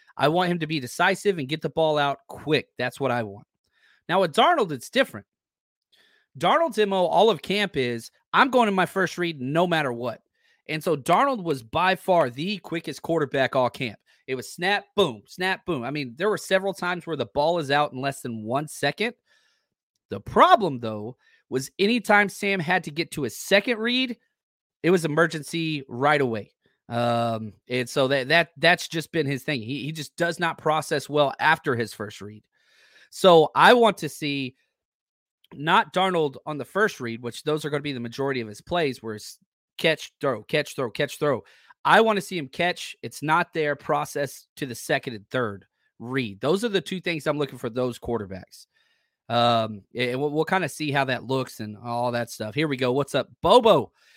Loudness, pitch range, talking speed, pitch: -24 LUFS, 125-180 Hz, 205 wpm, 150 Hz